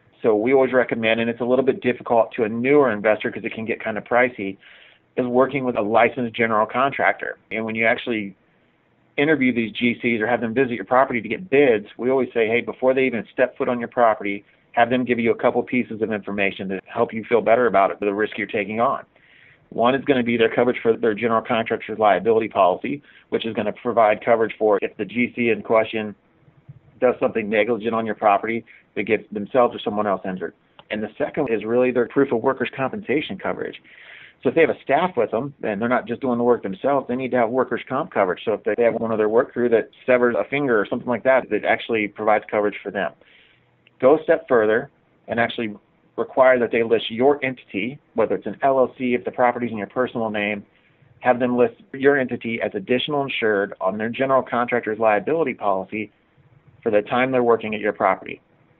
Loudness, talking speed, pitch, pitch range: -21 LUFS, 220 wpm, 120 Hz, 110-125 Hz